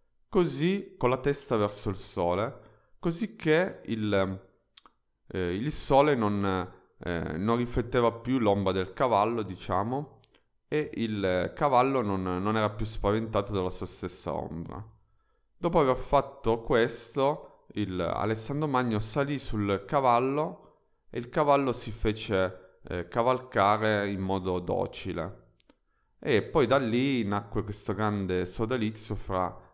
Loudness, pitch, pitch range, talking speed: -29 LUFS, 110 Hz, 95-125 Hz, 125 wpm